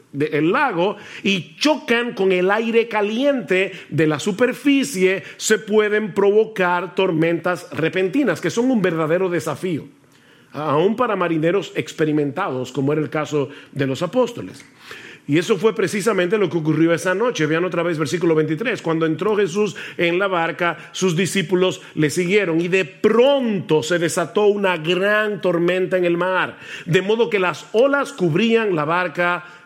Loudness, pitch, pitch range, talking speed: -19 LUFS, 180 Hz, 165-210 Hz, 150 wpm